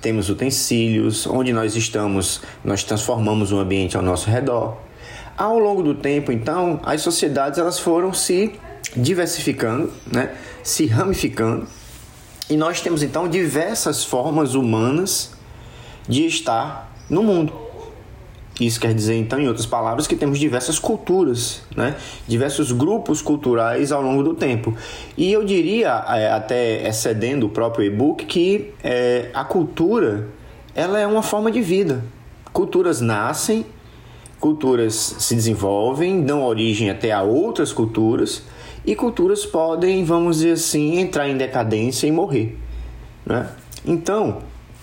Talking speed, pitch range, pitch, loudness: 135 wpm, 115-165 Hz, 130 Hz, -20 LUFS